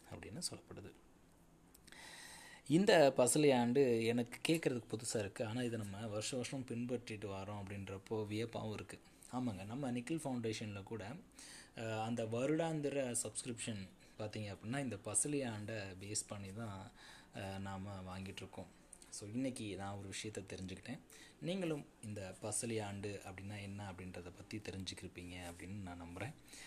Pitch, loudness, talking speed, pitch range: 110 Hz, -41 LUFS, 125 wpm, 100-120 Hz